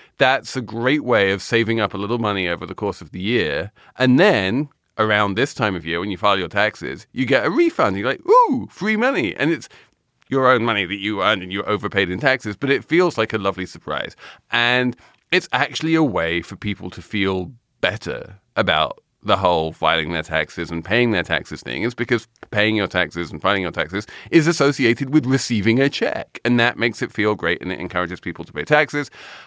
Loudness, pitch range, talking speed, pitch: -20 LUFS, 95-130 Hz, 225 wpm, 110 Hz